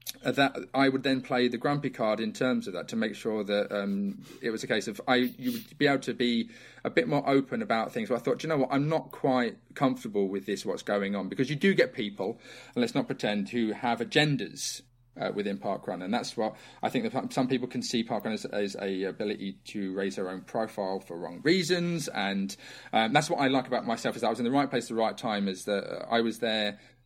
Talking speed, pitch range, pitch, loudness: 255 wpm, 100-135 Hz, 120 Hz, -30 LUFS